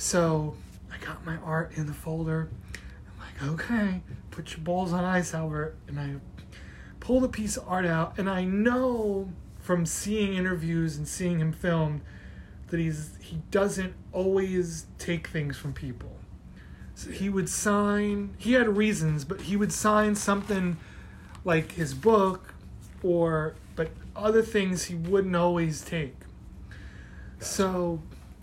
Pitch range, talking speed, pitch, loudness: 155-195 Hz, 145 wpm, 175 Hz, -28 LUFS